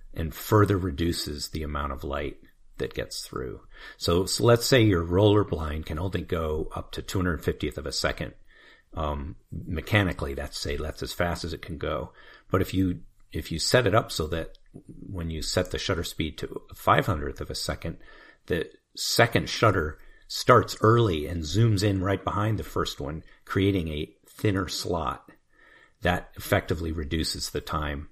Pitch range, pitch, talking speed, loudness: 80-100 Hz, 85 Hz, 170 wpm, -27 LUFS